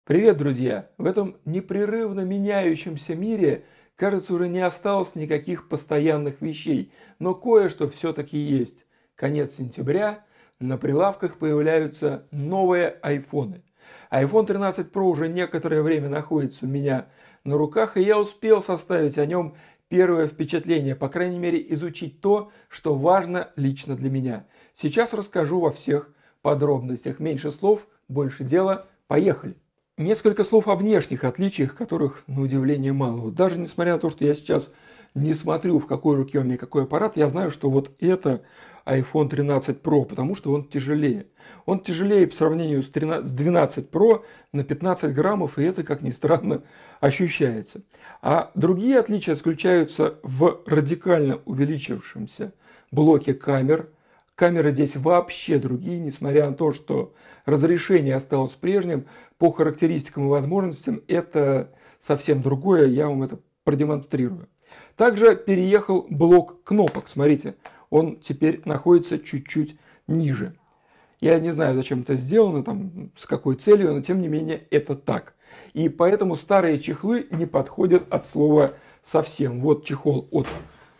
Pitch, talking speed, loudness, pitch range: 160 Hz, 140 wpm, -22 LUFS, 145-185 Hz